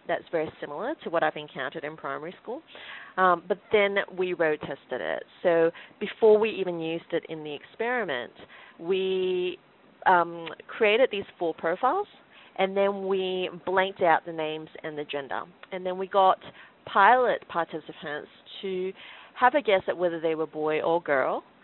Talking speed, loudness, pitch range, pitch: 165 wpm, -27 LUFS, 160-200 Hz, 180 Hz